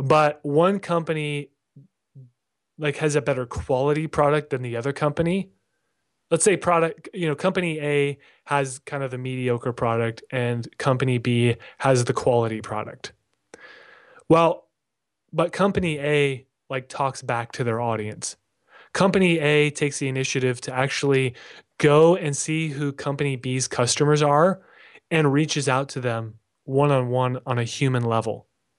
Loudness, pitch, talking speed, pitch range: -23 LUFS, 140 Hz, 140 wpm, 125-150 Hz